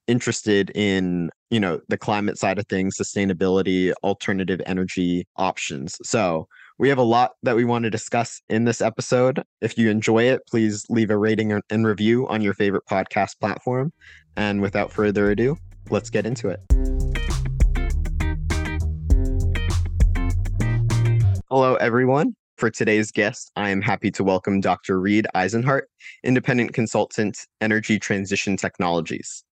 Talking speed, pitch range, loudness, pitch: 135 wpm, 90-115 Hz, -22 LUFS, 105 Hz